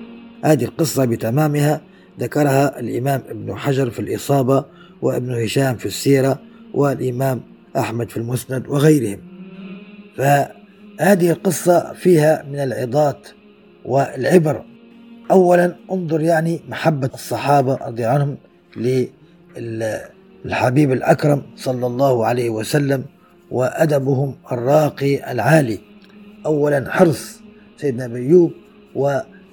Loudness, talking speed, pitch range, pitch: -18 LUFS, 90 wpm, 130-180 Hz, 145 Hz